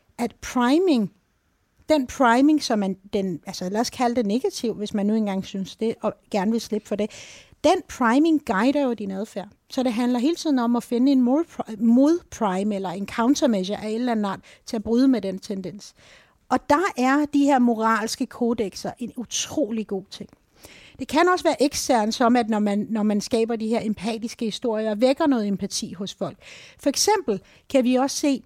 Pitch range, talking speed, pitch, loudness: 210-265 Hz, 195 wpm, 230 Hz, -23 LUFS